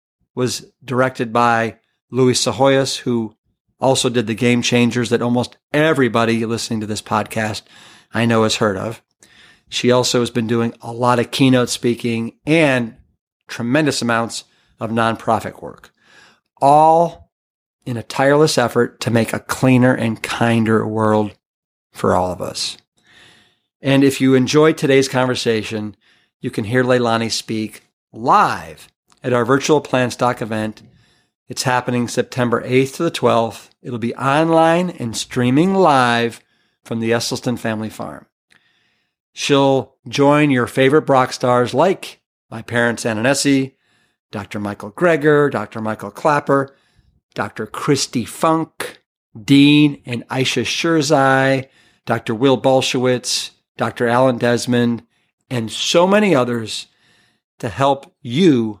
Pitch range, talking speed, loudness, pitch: 115-135 Hz, 130 wpm, -17 LUFS, 125 Hz